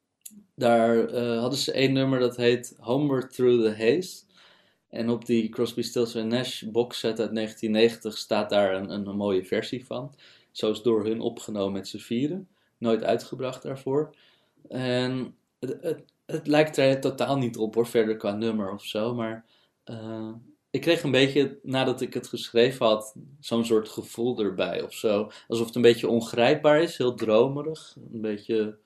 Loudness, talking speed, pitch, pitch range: -26 LUFS, 170 wpm, 120 Hz, 110-130 Hz